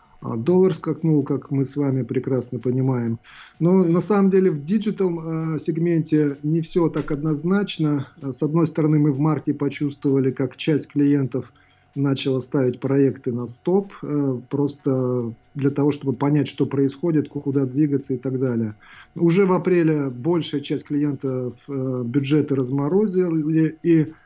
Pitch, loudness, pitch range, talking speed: 145 Hz, -22 LUFS, 135-160 Hz, 135 wpm